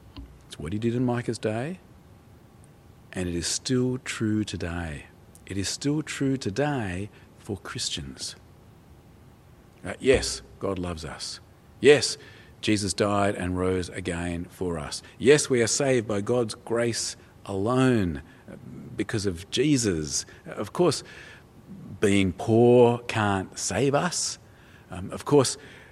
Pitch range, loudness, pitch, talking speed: 90-120 Hz, -26 LUFS, 105 Hz, 125 wpm